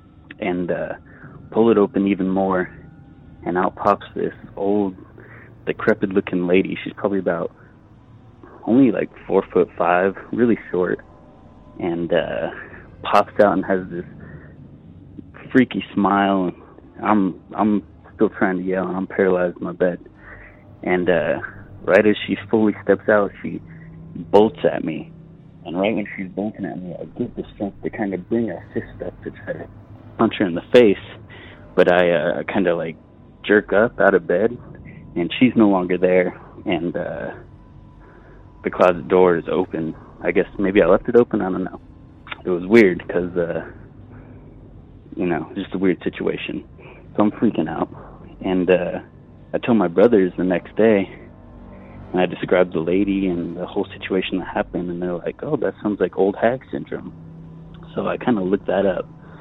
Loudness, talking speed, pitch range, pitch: -20 LUFS, 170 wpm, 90-105 Hz, 95 Hz